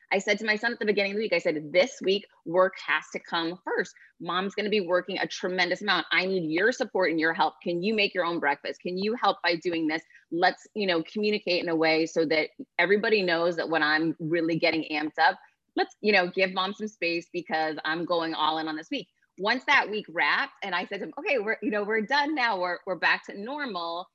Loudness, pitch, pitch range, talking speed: -27 LUFS, 180 Hz, 165-210 Hz, 250 wpm